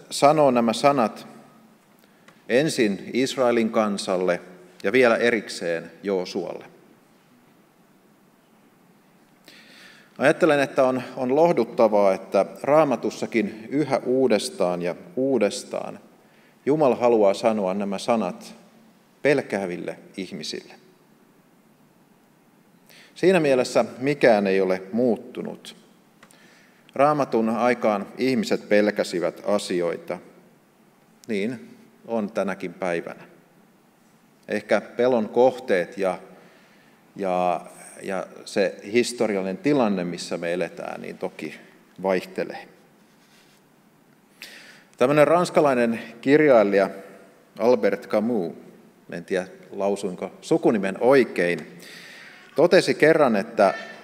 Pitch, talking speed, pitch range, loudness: 115 Hz, 80 wpm, 95-130 Hz, -22 LUFS